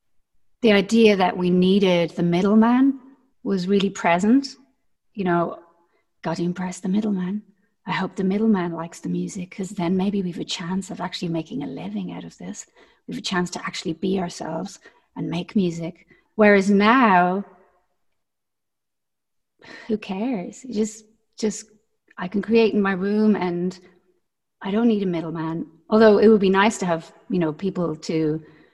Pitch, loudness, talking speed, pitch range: 190 Hz, -21 LUFS, 165 wpm, 180-215 Hz